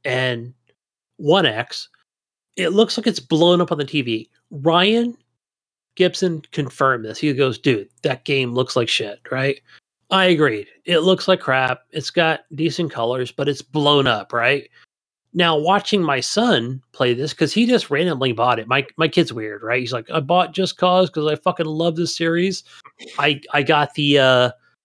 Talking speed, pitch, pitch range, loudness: 175 wpm, 150 Hz, 130-170 Hz, -19 LUFS